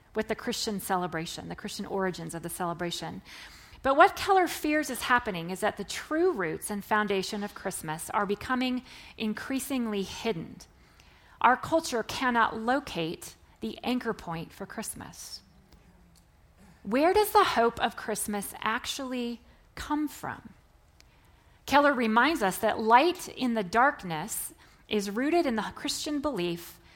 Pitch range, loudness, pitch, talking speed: 190-260 Hz, -28 LUFS, 220 Hz, 135 wpm